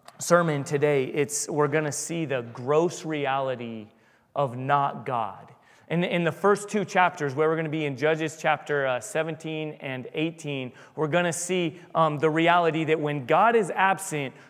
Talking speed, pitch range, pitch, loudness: 160 wpm, 145-165 Hz, 155 Hz, -25 LUFS